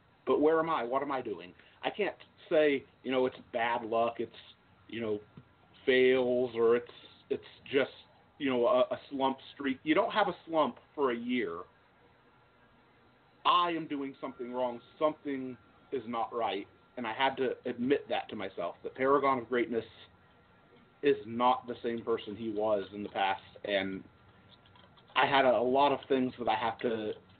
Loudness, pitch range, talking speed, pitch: -32 LUFS, 115-135 Hz, 175 wpm, 125 Hz